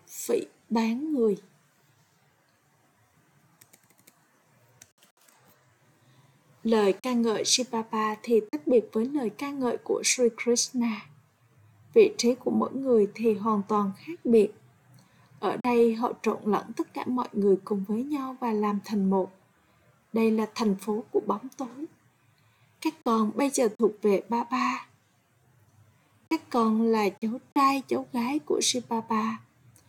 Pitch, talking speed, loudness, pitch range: 225 Hz, 135 wpm, -27 LUFS, 195-250 Hz